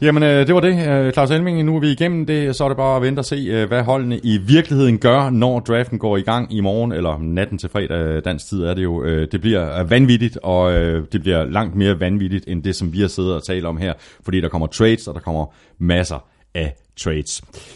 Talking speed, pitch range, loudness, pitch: 235 wpm, 85-130 Hz, -18 LUFS, 100 Hz